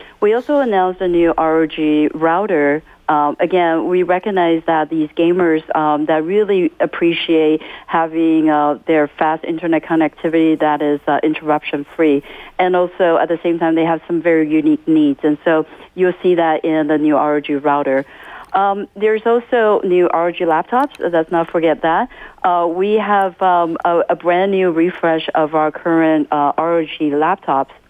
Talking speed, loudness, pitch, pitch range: 165 wpm, -15 LUFS, 165 Hz, 155-180 Hz